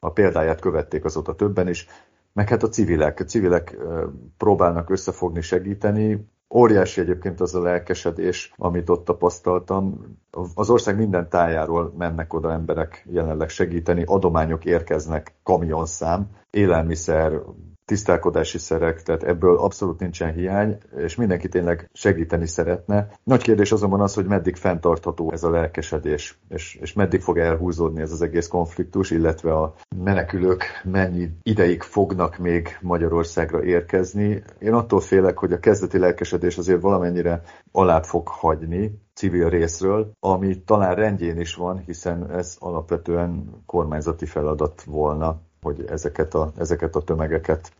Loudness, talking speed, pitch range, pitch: -22 LUFS, 135 wpm, 85-95 Hz, 90 Hz